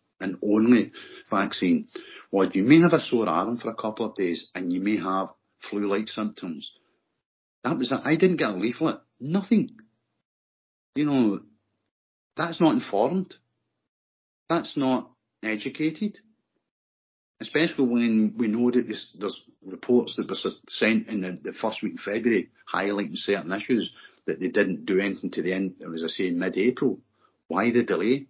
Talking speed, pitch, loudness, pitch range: 160 wpm, 115 Hz, -25 LUFS, 95-155 Hz